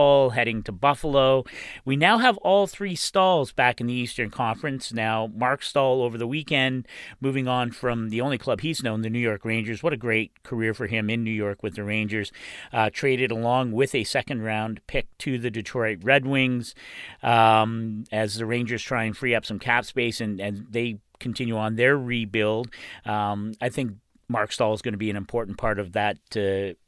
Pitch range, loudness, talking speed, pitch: 110-130 Hz, -24 LUFS, 200 wpm, 115 Hz